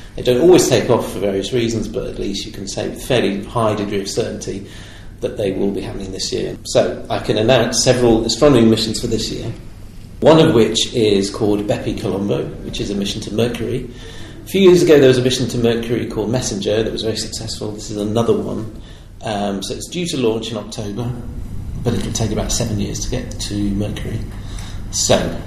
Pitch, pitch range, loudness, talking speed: 110 Hz, 105-120 Hz, -17 LUFS, 210 wpm